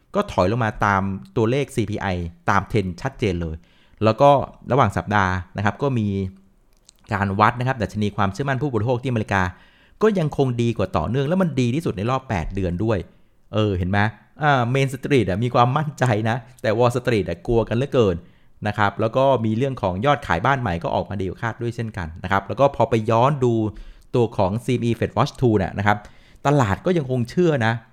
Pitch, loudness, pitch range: 110 Hz, -21 LUFS, 100-130 Hz